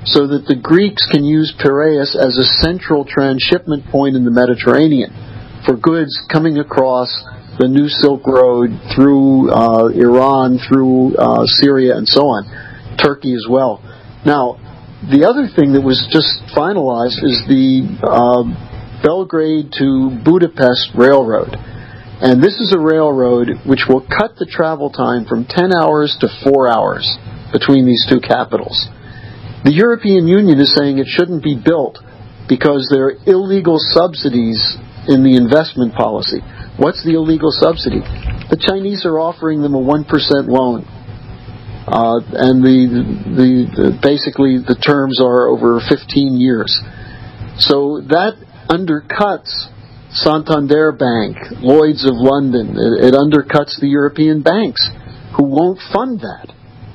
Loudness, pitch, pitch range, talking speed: -12 LUFS, 135 Hz, 120-150 Hz, 140 wpm